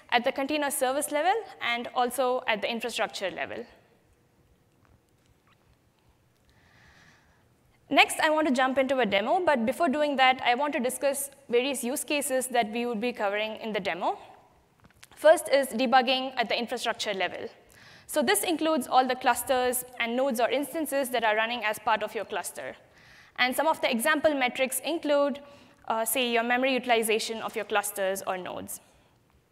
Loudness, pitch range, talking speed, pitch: -27 LUFS, 235-290 Hz, 165 wpm, 260 Hz